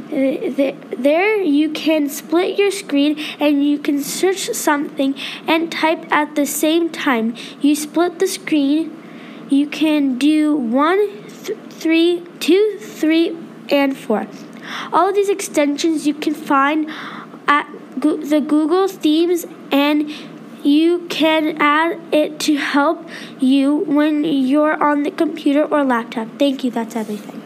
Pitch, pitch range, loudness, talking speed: 300 Hz, 280-325 Hz, -17 LUFS, 135 wpm